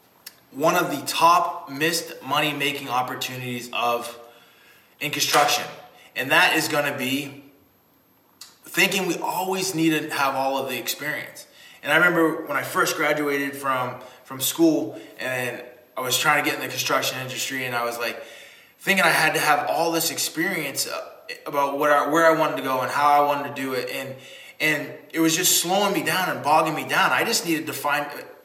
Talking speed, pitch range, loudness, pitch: 190 wpm, 130-160 Hz, -22 LUFS, 145 Hz